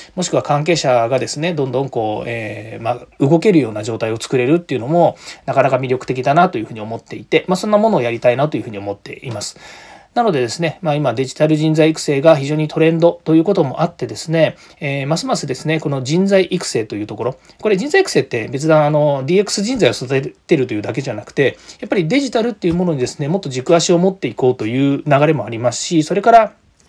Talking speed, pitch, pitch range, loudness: 480 characters per minute, 155 Hz, 130-175 Hz, -16 LUFS